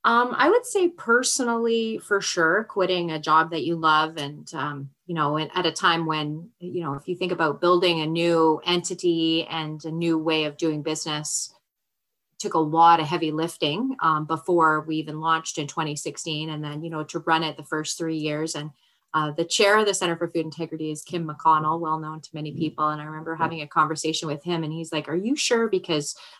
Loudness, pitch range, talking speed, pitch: -24 LUFS, 155-175 Hz, 215 wpm, 160 Hz